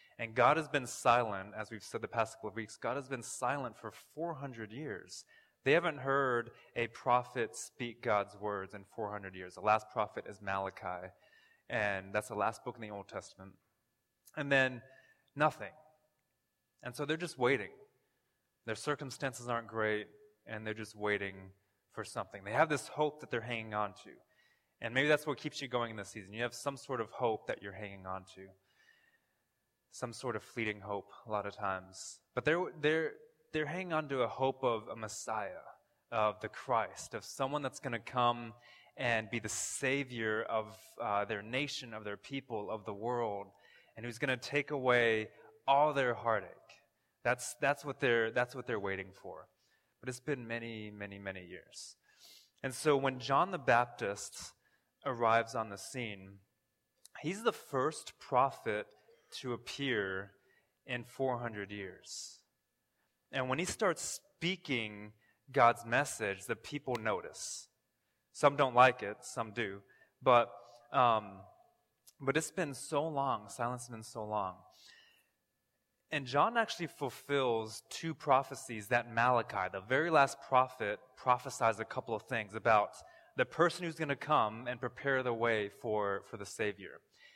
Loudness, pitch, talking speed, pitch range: -35 LUFS, 120 Hz, 165 wpm, 105-135 Hz